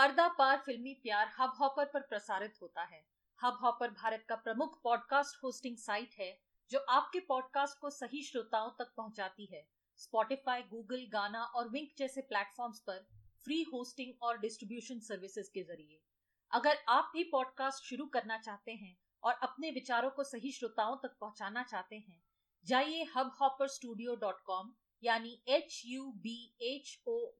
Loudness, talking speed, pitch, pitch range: -38 LUFS, 150 wpm, 245 Hz, 220-275 Hz